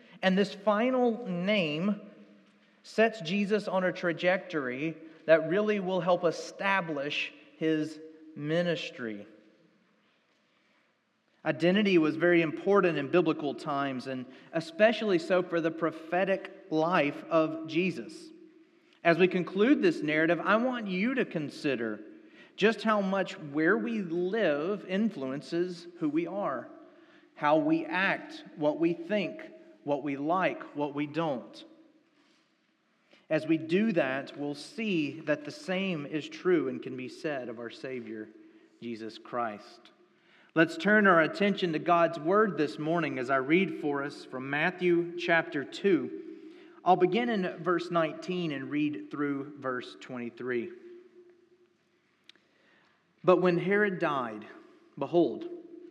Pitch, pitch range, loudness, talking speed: 175 Hz, 155-220 Hz, -29 LUFS, 125 wpm